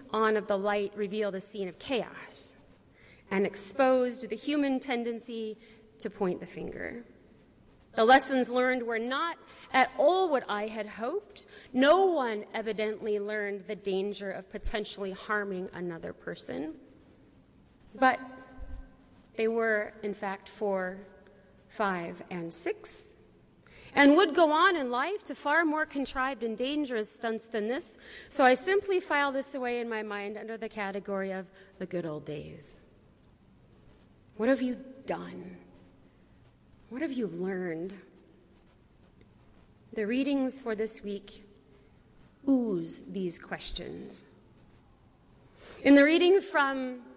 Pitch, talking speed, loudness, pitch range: 225 Hz, 130 wpm, -30 LUFS, 200-270 Hz